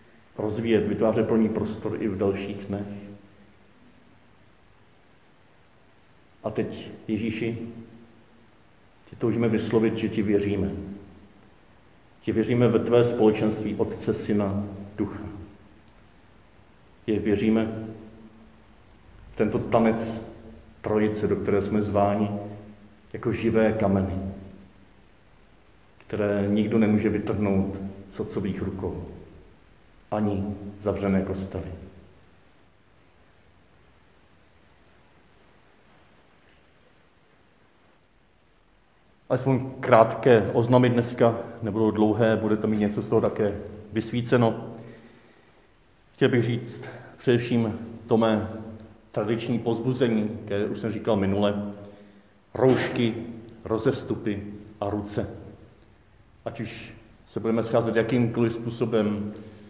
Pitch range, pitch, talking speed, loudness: 100-115 Hz, 110 Hz, 85 wpm, -25 LUFS